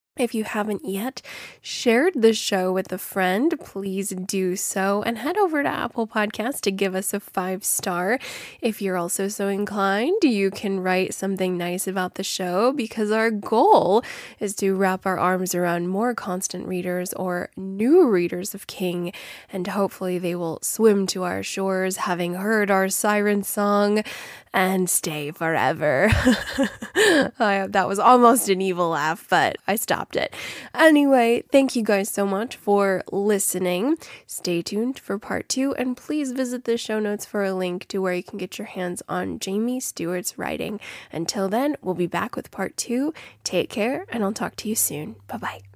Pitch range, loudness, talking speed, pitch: 185-230 Hz, -23 LUFS, 175 wpm, 195 Hz